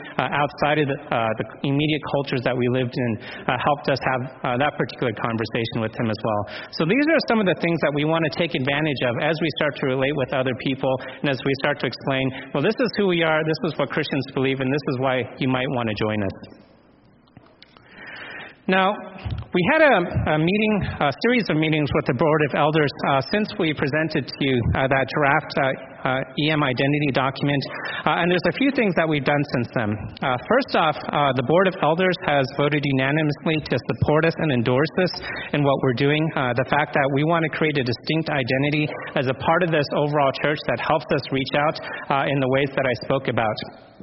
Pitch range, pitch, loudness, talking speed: 130-160 Hz, 145 Hz, -22 LUFS, 225 wpm